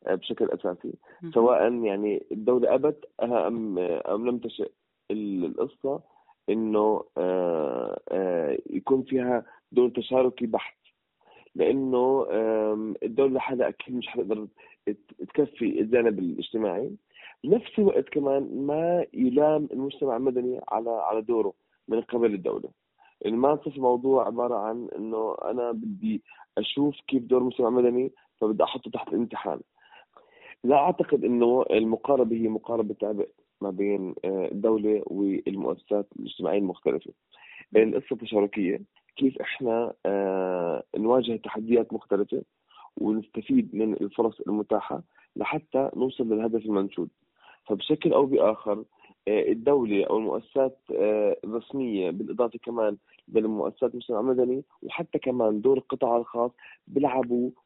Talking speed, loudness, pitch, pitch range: 105 wpm, -27 LUFS, 120 Hz, 110-135 Hz